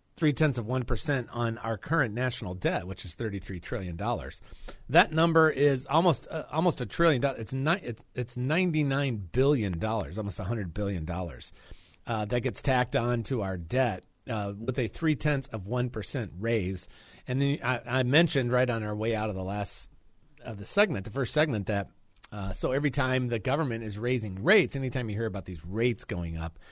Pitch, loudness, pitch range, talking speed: 120 Hz, -29 LUFS, 100-135 Hz, 200 wpm